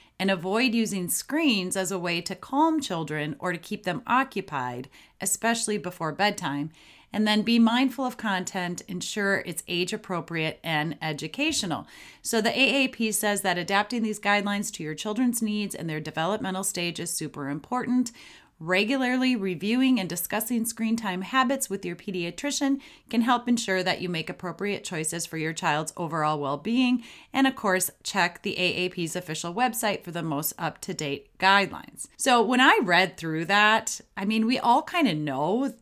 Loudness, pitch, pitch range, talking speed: -26 LUFS, 195 Hz, 175-235 Hz, 170 wpm